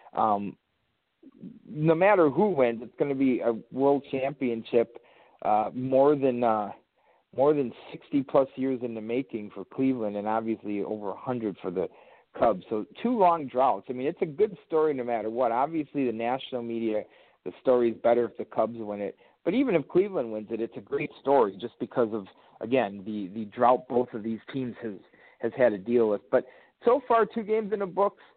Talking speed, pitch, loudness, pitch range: 195 wpm, 125 Hz, -27 LUFS, 110-155 Hz